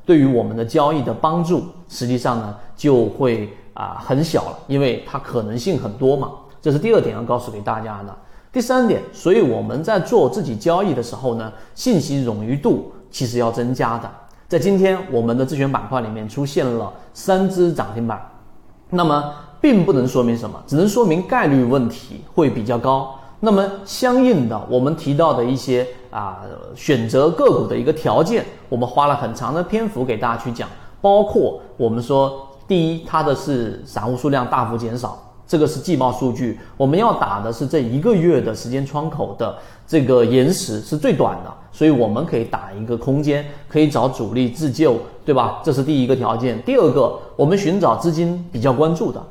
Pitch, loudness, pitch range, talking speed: 130 Hz, -18 LUFS, 120-155 Hz, 290 characters per minute